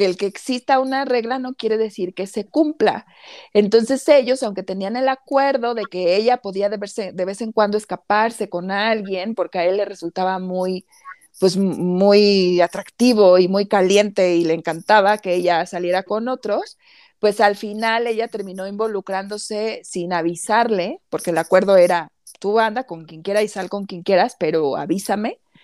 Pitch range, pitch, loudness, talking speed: 185-230 Hz, 205 Hz, -19 LUFS, 175 wpm